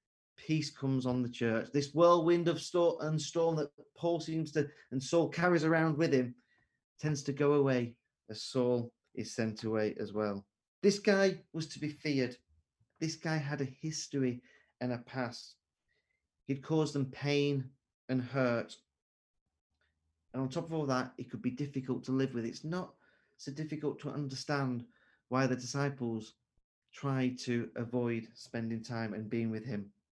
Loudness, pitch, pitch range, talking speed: -34 LUFS, 130 Hz, 120-150 Hz, 165 wpm